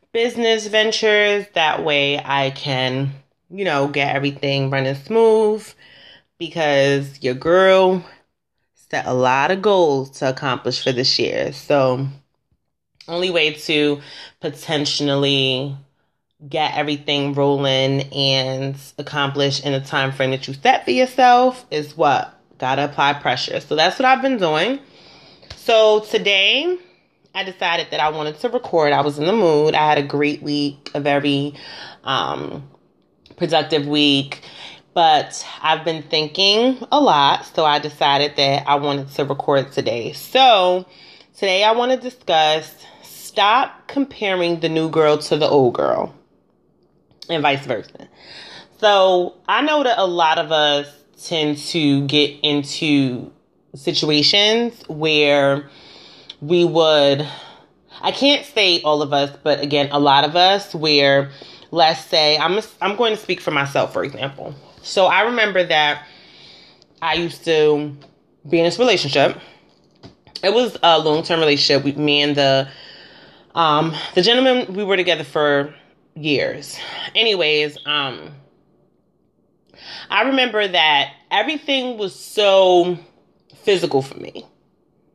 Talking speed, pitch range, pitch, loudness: 135 wpm, 140-185 Hz, 150 Hz, -17 LUFS